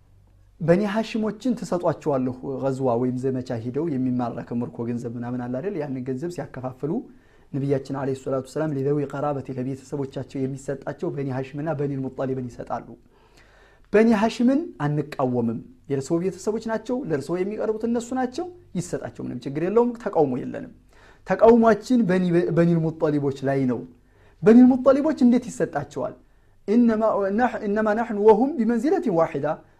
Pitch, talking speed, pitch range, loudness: 150 Hz, 115 wpm, 130-215 Hz, -23 LUFS